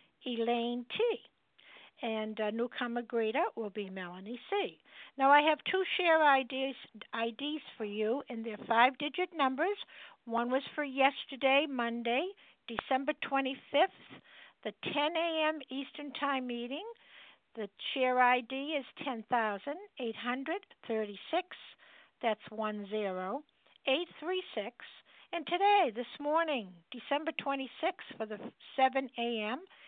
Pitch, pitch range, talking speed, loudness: 265 Hz, 230-300 Hz, 110 wpm, -33 LUFS